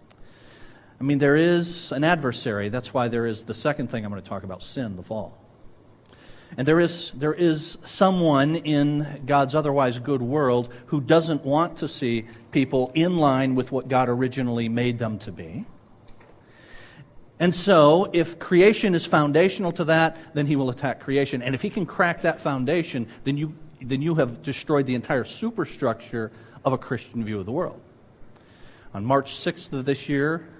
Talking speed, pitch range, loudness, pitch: 175 wpm, 120-160 Hz, -23 LUFS, 140 Hz